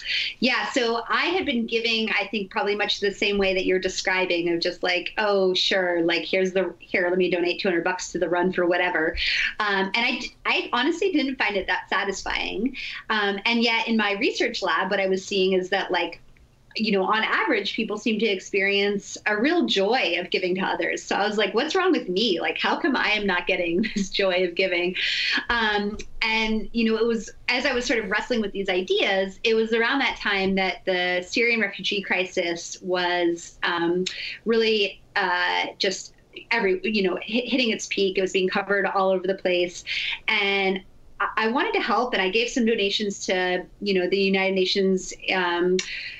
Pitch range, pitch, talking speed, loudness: 185-225 Hz, 195 Hz, 205 wpm, -23 LUFS